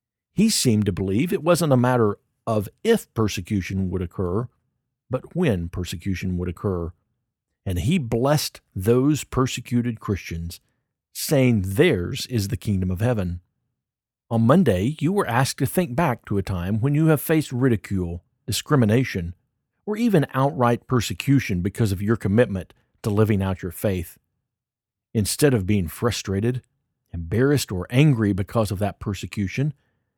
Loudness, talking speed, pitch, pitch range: -23 LUFS, 145 wpm, 115 Hz, 100-130 Hz